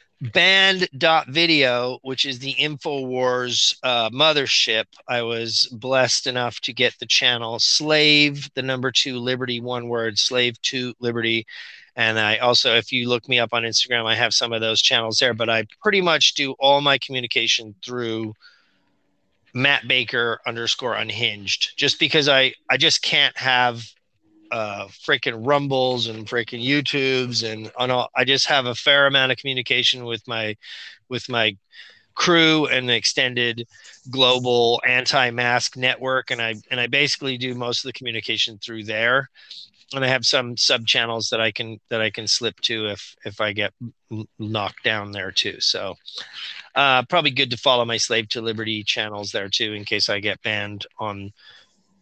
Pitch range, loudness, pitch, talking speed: 115-130 Hz, -19 LUFS, 120 Hz, 165 wpm